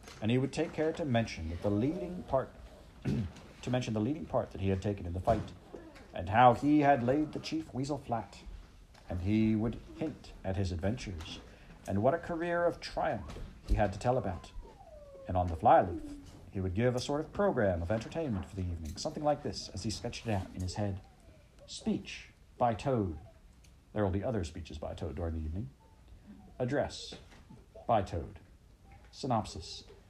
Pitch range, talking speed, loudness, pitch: 95-125 Hz, 185 wpm, -34 LUFS, 105 Hz